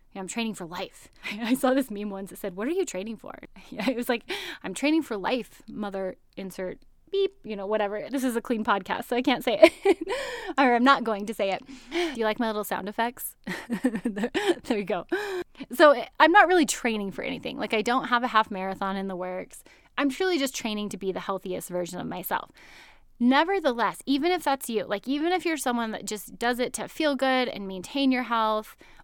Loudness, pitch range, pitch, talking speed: -26 LUFS, 210-280 Hz, 240 Hz, 215 wpm